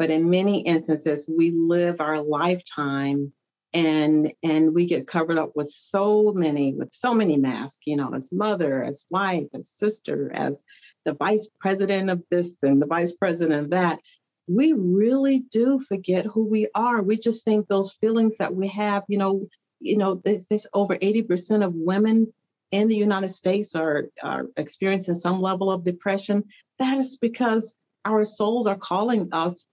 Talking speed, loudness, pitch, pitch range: 170 wpm, -23 LUFS, 195 Hz, 165-210 Hz